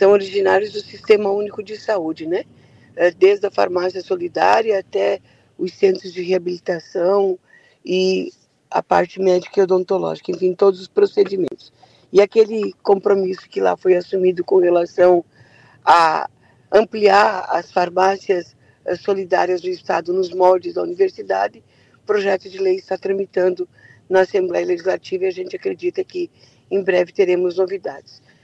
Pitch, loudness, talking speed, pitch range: 190 Hz, -18 LUFS, 135 wpm, 180-205 Hz